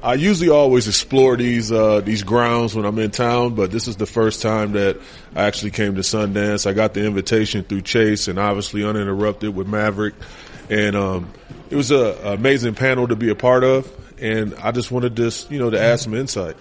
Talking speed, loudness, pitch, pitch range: 215 wpm, -18 LUFS, 110 Hz, 105-120 Hz